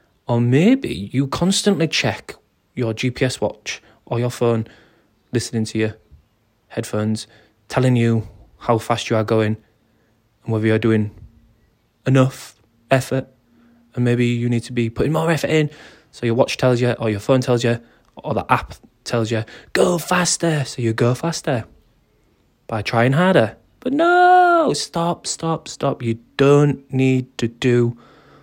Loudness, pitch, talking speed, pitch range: -19 LUFS, 120 Hz, 150 wpm, 115-140 Hz